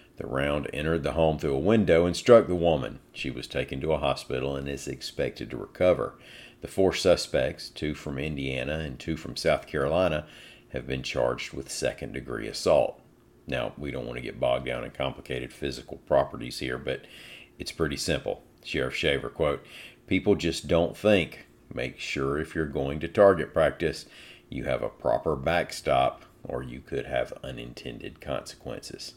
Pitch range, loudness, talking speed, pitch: 70-85 Hz, -28 LUFS, 175 wpm, 80 Hz